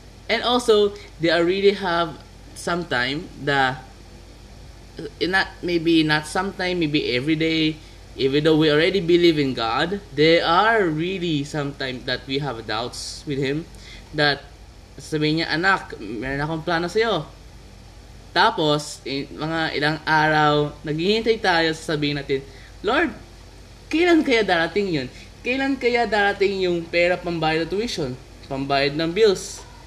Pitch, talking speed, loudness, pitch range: 155 Hz, 125 wpm, -21 LUFS, 135-175 Hz